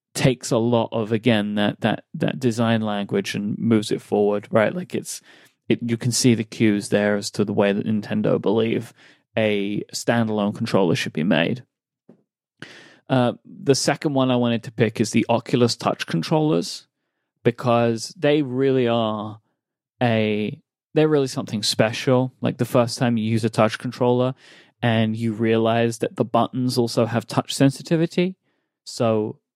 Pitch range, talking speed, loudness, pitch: 110-130 Hz, 160 wpm, -21 LUFS, 120 Hz